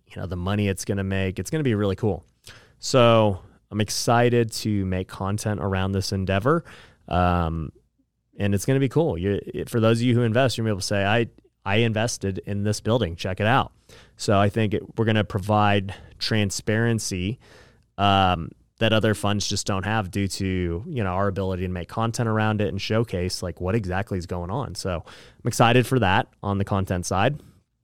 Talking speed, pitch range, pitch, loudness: 205 wpm, 95-115 Hz, 105 Hz, -24 LUFS